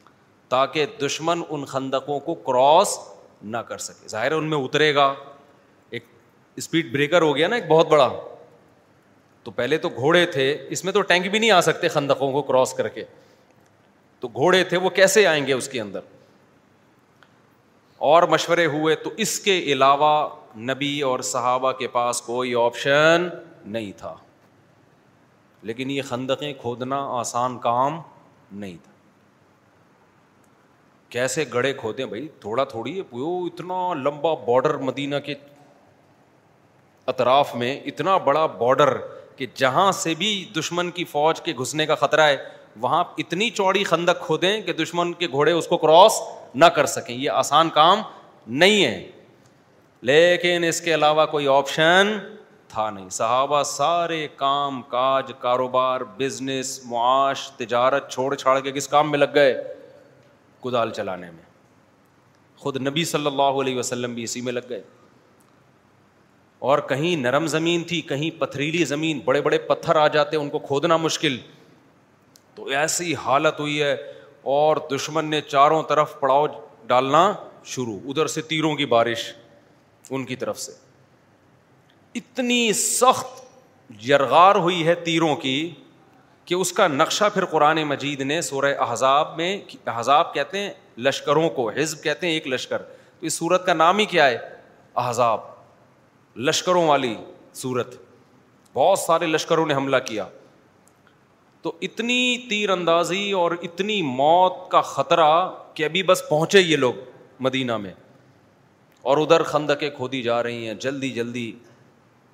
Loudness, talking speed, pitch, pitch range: -21 LUFS, 145 wpm, 150 Hz, 135-170 Hz